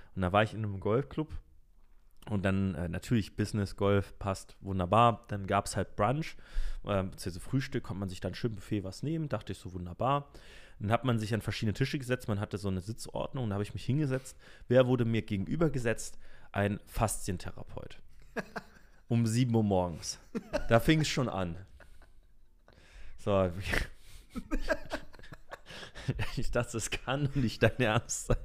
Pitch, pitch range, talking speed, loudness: 105 Hz, 95-120 Hz, 165 wpm, -33 LUFS